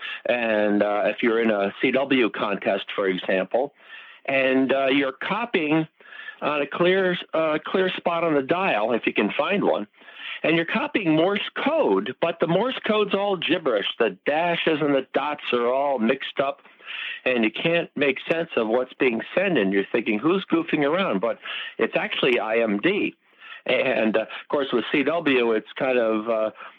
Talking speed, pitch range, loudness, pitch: 170 wpm, 115-170 Hz, -23 LUFS, 140 Hz